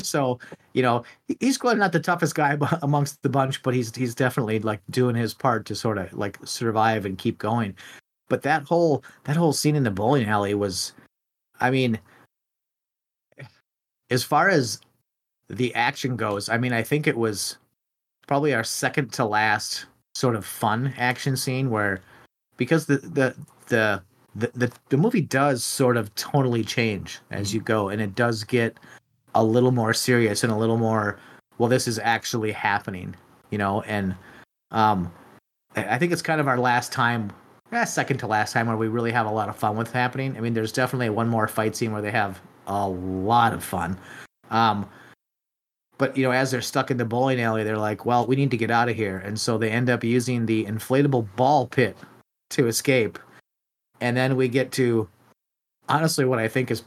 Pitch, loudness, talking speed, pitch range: 120 Hz, -24 LUFS, 190 wpm, 110-130 Hz